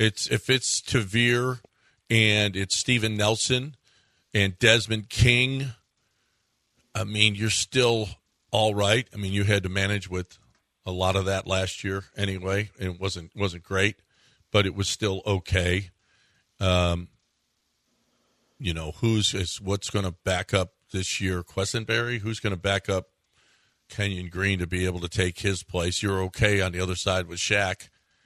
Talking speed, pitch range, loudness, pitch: 155 wpm, 95-110 Hz, -25 LUFS, 100 Hz